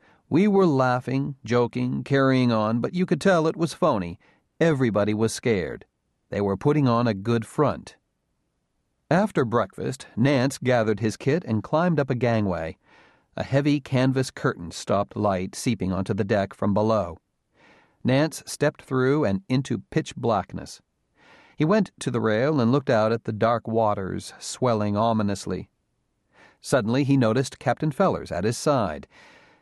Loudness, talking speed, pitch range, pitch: -24 LUFS, 150 wpm, 110-140 Hz, 125 Hz